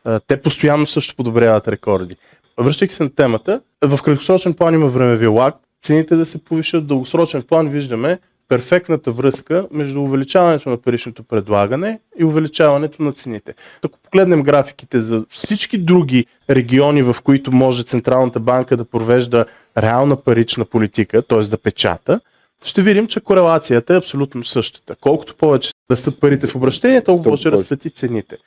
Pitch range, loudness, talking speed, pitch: 120-160 Hz, -15 LUFS, 155 wpm, 140 Hz